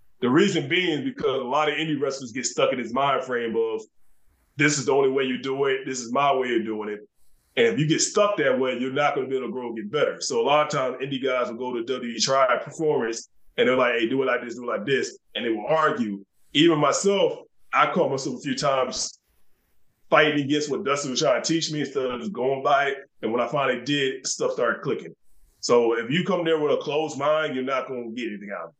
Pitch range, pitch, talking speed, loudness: 130-160 Hz, 140 Hz, 265 wpm, -24 LUFS